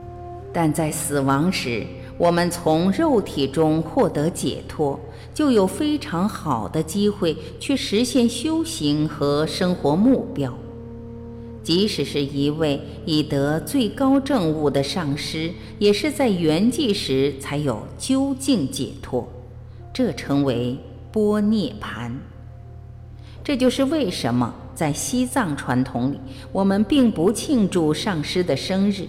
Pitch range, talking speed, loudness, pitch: 130-205 Hz, 180 characters per minute, -21 LUFS, 155 Hz